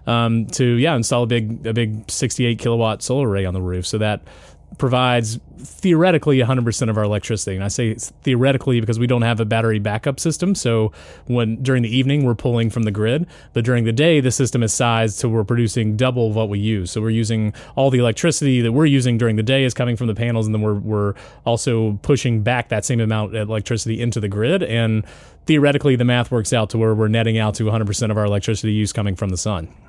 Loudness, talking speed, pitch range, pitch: -19 LUFS, 230 wpm, 110-125 Hz, 115 Hz